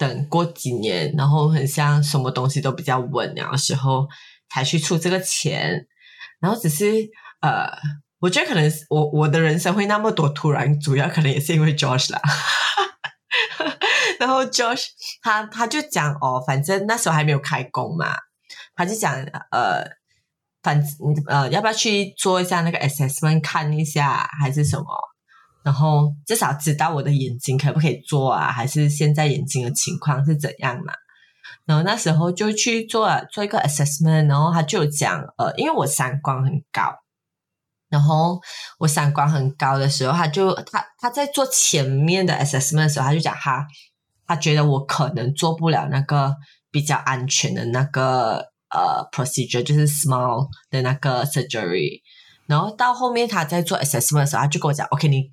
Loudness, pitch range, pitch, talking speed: -20 LUFS, 140-170 Hz, 150 Hz, 310 characters per minute